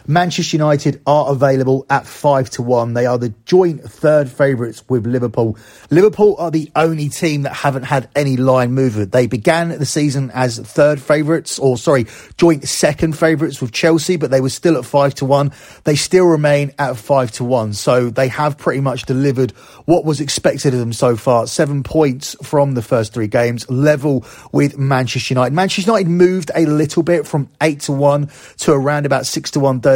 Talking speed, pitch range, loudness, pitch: 195 wpm, 130-155 Hz, -15 LUFS, 140 Hz